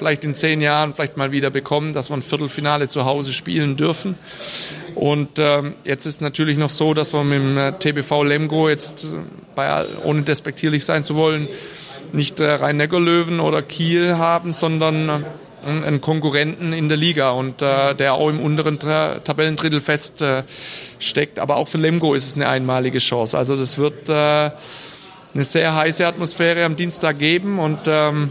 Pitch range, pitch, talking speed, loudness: 145-160 Hz, 150 Hz, 170 wpm, -19 LUFS